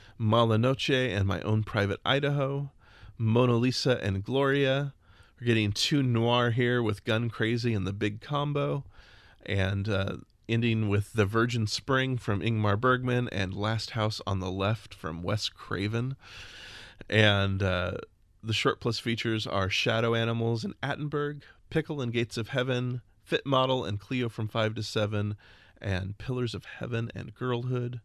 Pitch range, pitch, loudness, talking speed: 100-125 Hz, 115 Hz, -29 LUFS, 150 wpm